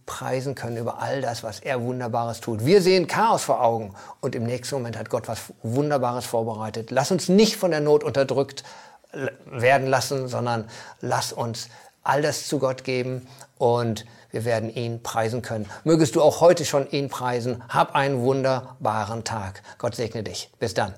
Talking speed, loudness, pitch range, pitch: 175 wpm, -24 LUFS, 115-140 Hz, 125 Hz